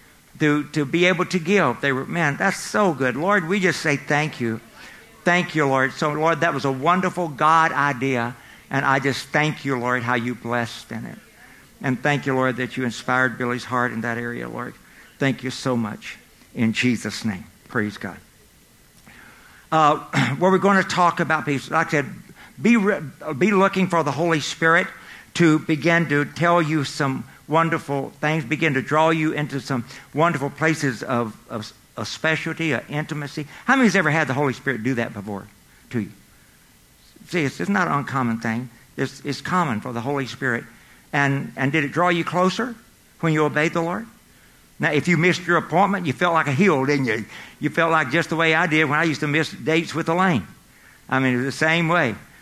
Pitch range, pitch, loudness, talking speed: 130-170 Hz, 150 Hz, -21 LUFS, 205 wpm